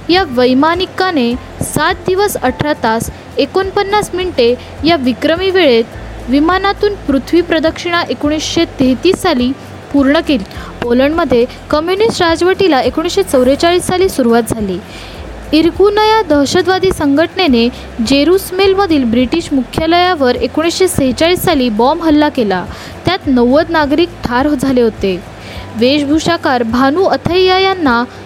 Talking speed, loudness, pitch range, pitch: 100 wpm, -12 LUFS, 255-360 Hz, 310 Hz